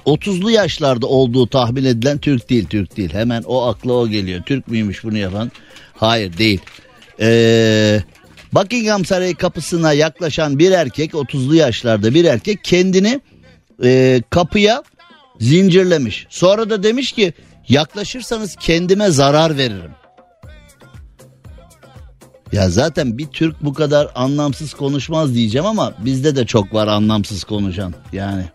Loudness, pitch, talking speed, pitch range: -15 LUFS, 130 Hz, 125 wpm, 110-170 Hz